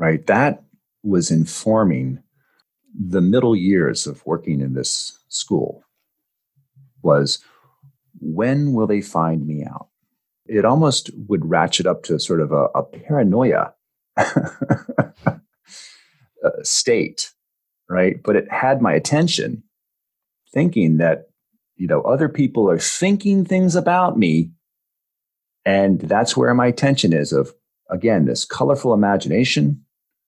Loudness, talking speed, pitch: -19 LUFS, 115 wpm, 105 Hz